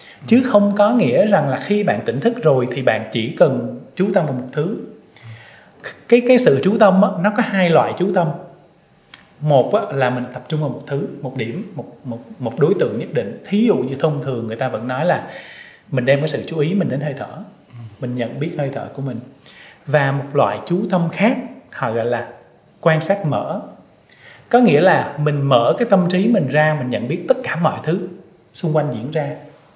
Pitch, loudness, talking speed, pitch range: 155 Hz, -18 LUFS, 220 wpm, 135-195 Hz